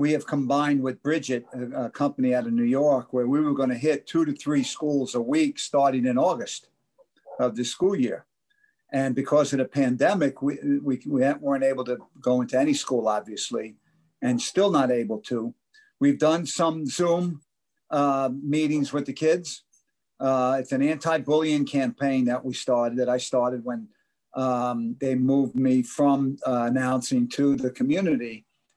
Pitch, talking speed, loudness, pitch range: 135 Hz, 175 wpm, -25 LUFS, 125-155 Hz